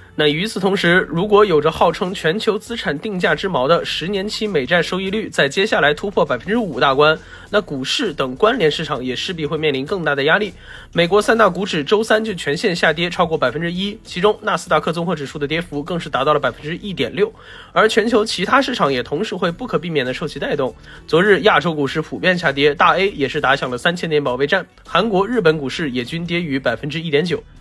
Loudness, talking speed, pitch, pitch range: -17 LUFS, 350 characters per minute, 170 Hz, 150-205 Hz